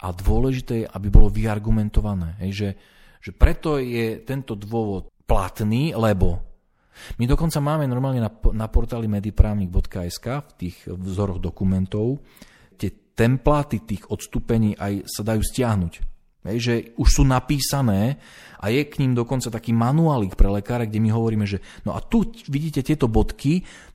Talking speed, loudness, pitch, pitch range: 140 wpm, -23 LUFS, 110 Hz, 100-130 Hz